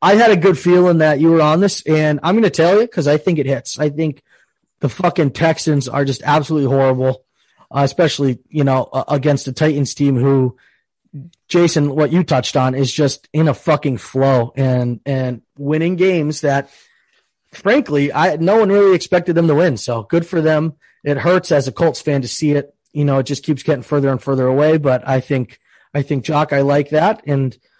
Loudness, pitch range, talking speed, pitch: -15 LUFS, 135-165 Hz, 205 wpm, 145 Hz